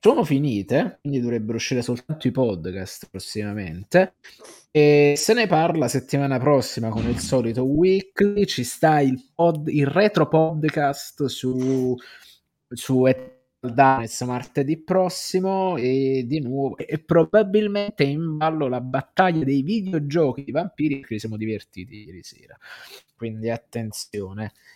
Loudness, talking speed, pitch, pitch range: -22 LUFS, 125 wpm, 135 Hz, 120-160 Hz